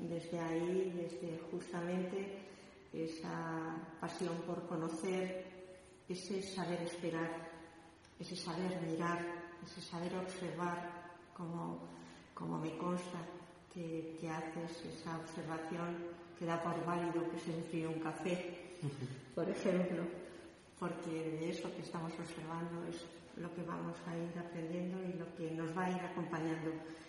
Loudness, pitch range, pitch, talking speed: -43 LUFS, 165-175 Hz, 170 Hz, 125 wpm